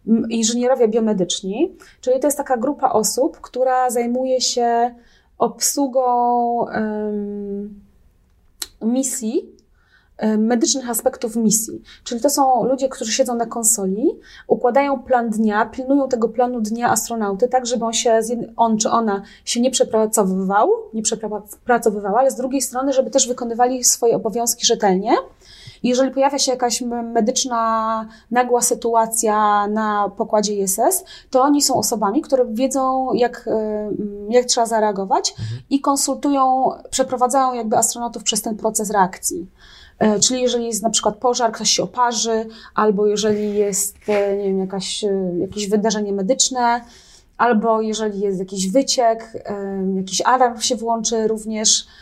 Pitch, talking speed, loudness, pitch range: 235 Hz, 130 wpm, -18 LUFS, 215-255 Hz